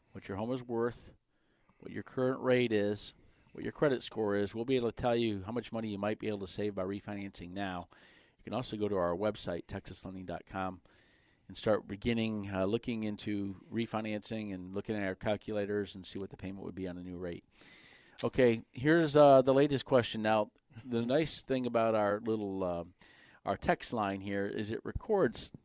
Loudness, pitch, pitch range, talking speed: -34 LUFS, 105 Hz, 100-115 Hz, 200 wpm